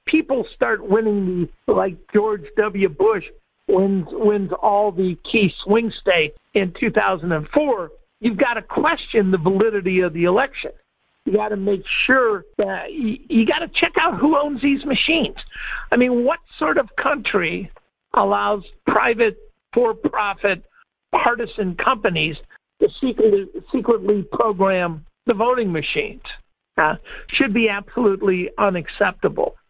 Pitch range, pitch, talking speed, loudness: 195-310 Hz, 220 Hz, 135 wpm, -19 LUFS